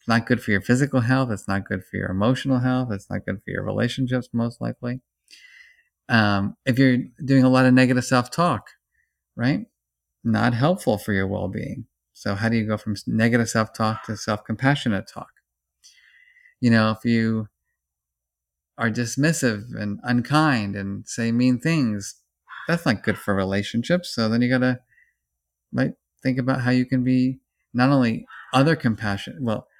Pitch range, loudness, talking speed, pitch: 105-130 Hz, -22 LUFS, 165 wpm, 115 Hz